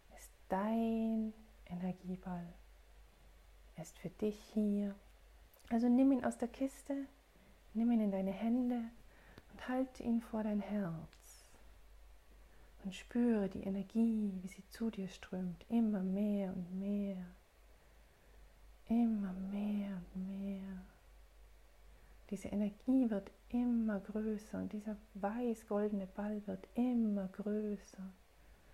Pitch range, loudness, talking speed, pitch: 190-225 Hz, -39 LUFS, 110 wpm, 205 Hz